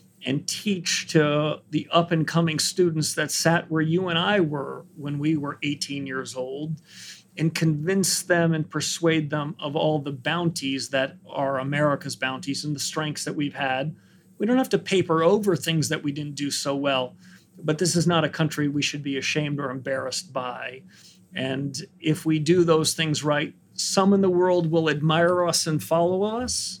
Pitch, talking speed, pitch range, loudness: 155 Hz, 190 wpm, 145-170 Hz, -24 LUFS